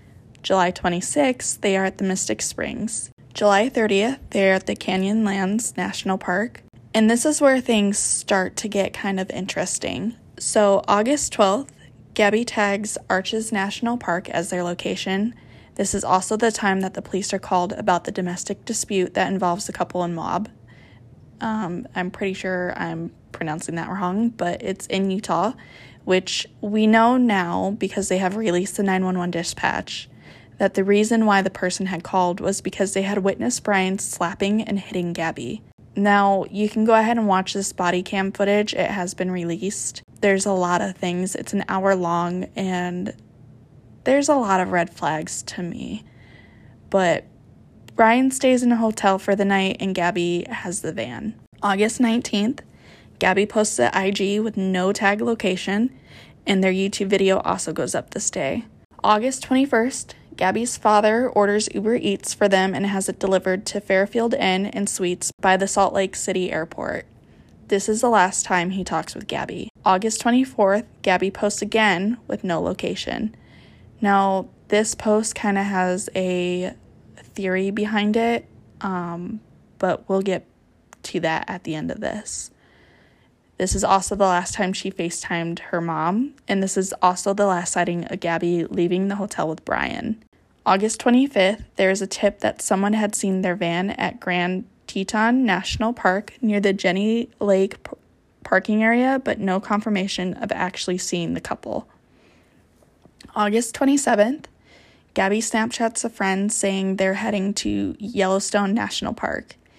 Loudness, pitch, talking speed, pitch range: -22 LUFS, 195 Hz, 160 wpm, 185-215 Hz